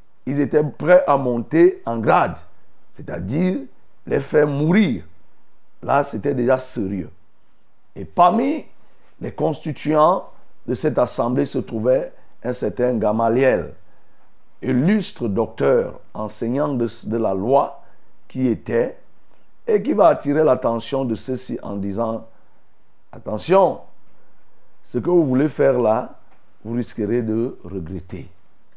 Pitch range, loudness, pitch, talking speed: 110-155 Hz, -20 LUFS, 130 Hz, 115 wpm